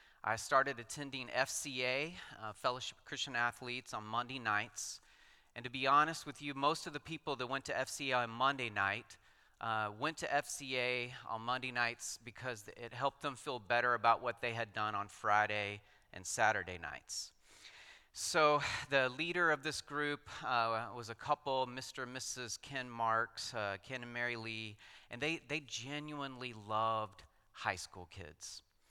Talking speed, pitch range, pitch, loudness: 165 wpm, 110-140 Hz, 125 Hz, -38 LUFS